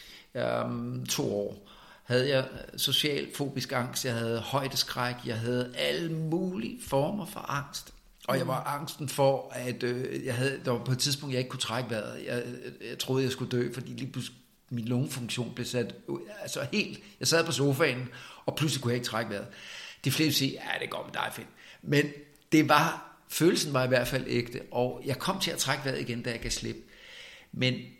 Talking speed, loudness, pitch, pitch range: 200 wpm, -30 LUFS, 130 Hz, 120-145 Hz